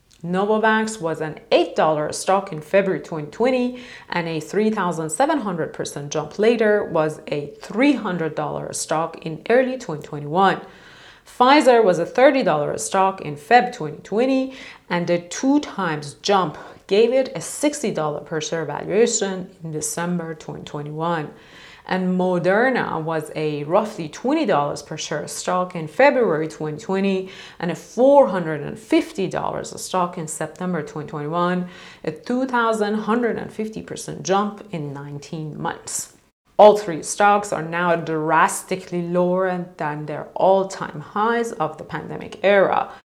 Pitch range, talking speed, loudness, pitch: 155-215 Hz, 120 wpm, -21 LUFS, 180 Hz